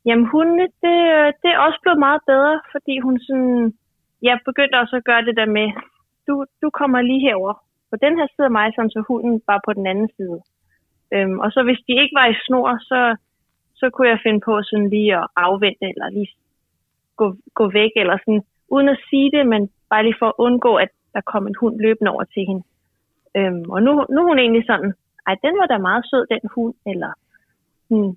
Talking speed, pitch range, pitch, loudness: 215 wpm, 210-270 Hz, 235 Hz, -17 LUFS